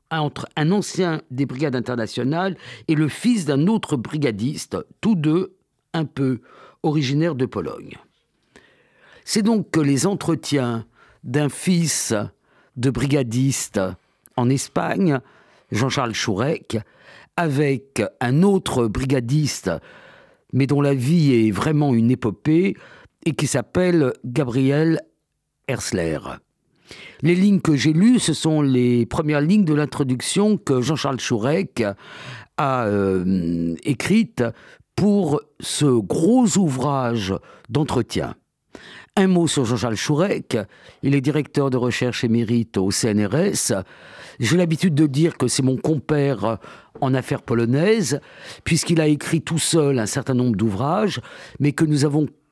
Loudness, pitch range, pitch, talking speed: -20 LUFS, 125-165 Hz, 145 Hz, 125 wpm